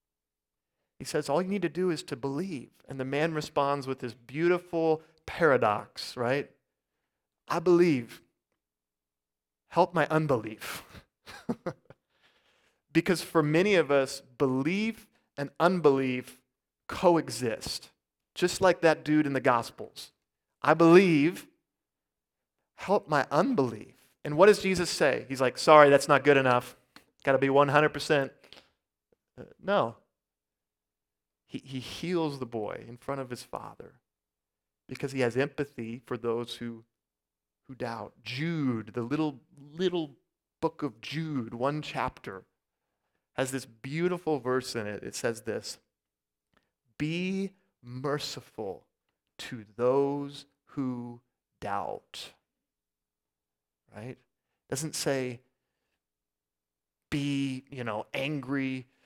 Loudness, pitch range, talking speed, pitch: -28 LUFS, 115-150 Hz, 115 wpm, 135 Hz